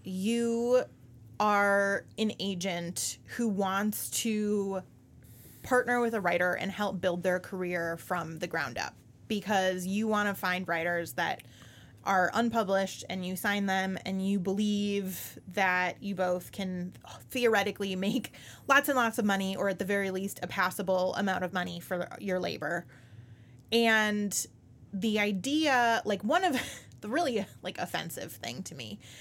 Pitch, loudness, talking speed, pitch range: 190 Hz, -30 LUFS, 150 wpm, 180-210 Hz